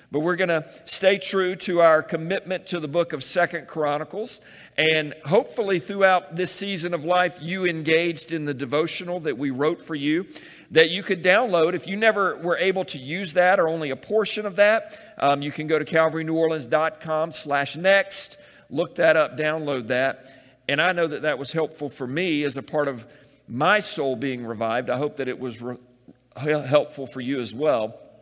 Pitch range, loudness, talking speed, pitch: 145-180 Hz, -23 LUFS, 195 wpm, 160 Hz